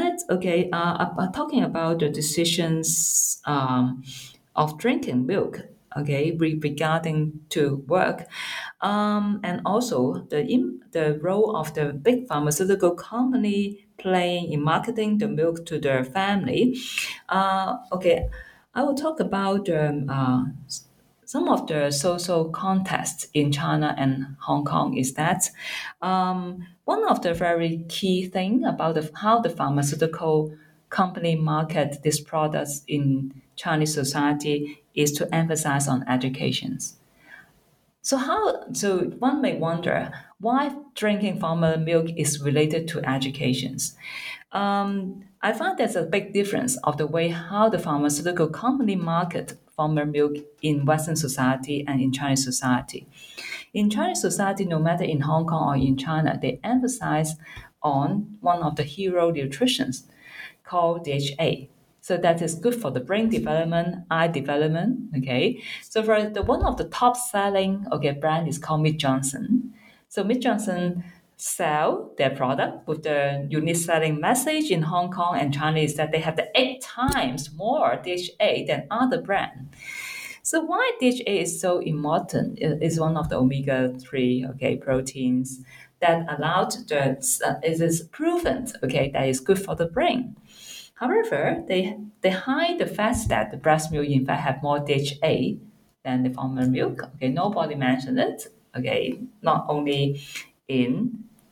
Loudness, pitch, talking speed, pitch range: -24 LUFS, 165 Hz, 145 wpm, 145-200 Hz